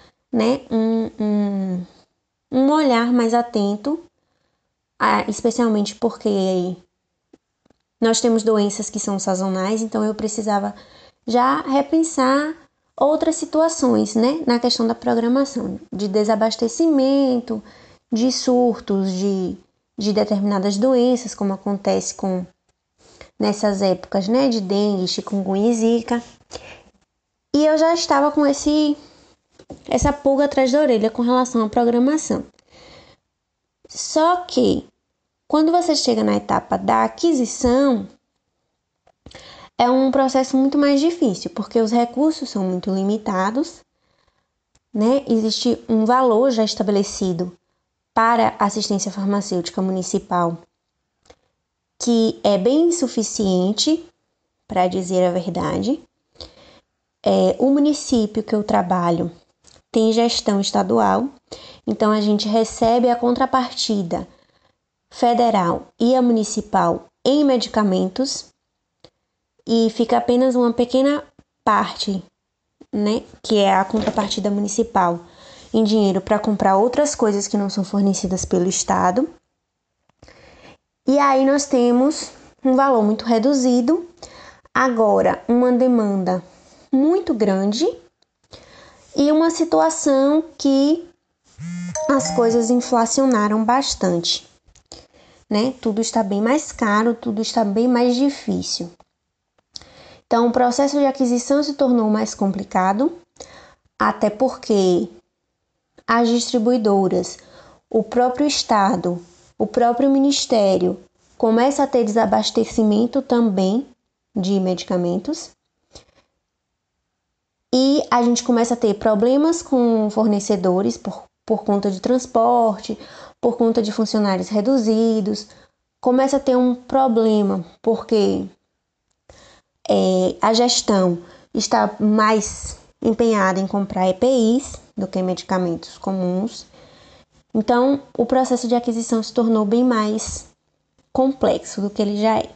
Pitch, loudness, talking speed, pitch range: 230 Hz, -19 LUFS, 105 wpm, 205-260 Hz